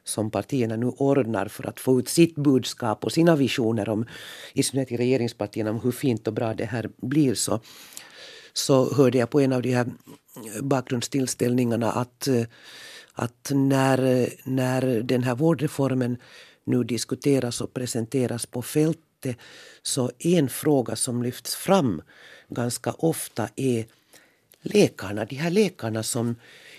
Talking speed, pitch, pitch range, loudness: 140 wpm, 125 Hz, 115-135 Hz, -24 LUFS